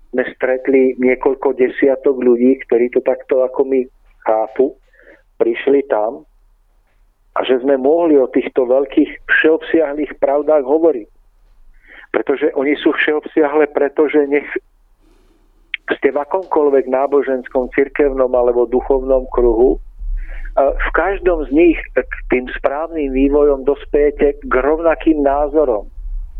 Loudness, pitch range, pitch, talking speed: -15 LUFS, 130-155 Hz, 140 Hz, 110 wpm